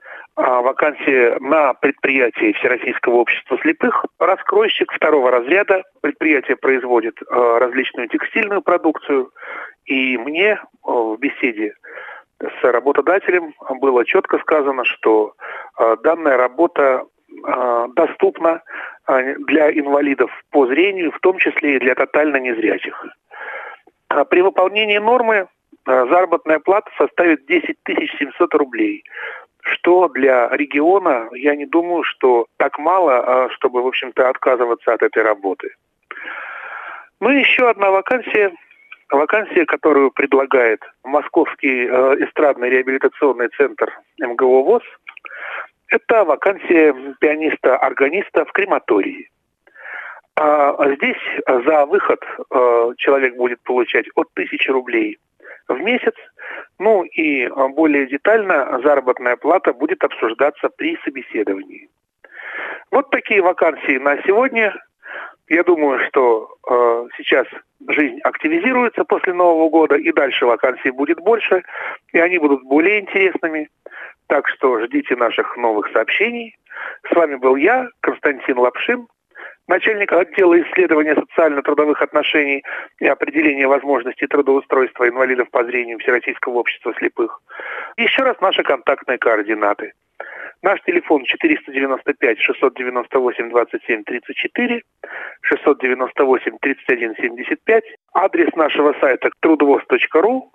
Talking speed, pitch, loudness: 100 wpm, 170 Hz, -16 LUFS